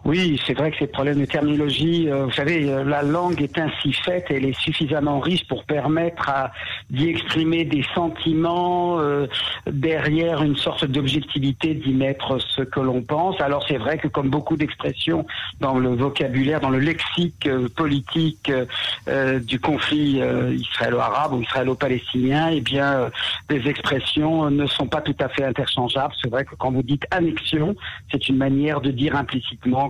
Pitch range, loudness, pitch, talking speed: 135-155 Hz, -21 LUFS, 145 Hz, 170 wpm